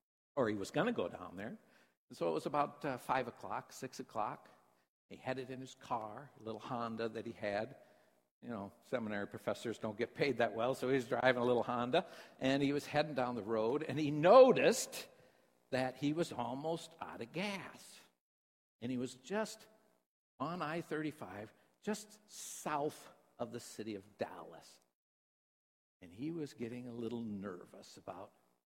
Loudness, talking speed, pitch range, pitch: -37 LUFS, 175 wpm, 110-150 Hz, 125 Hz